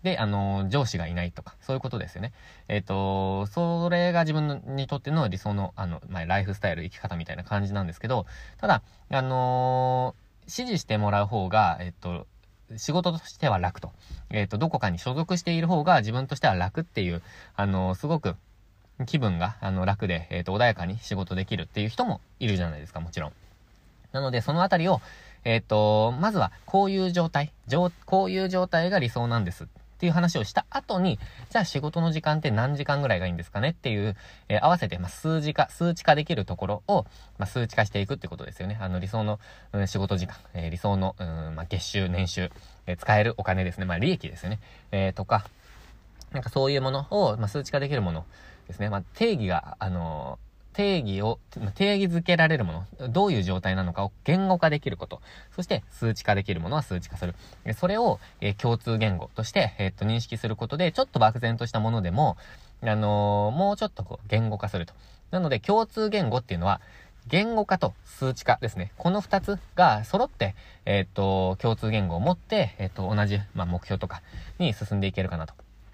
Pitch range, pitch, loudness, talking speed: 95-145 Hz, 105 Hz, -27 LUFS, 400 characters per minute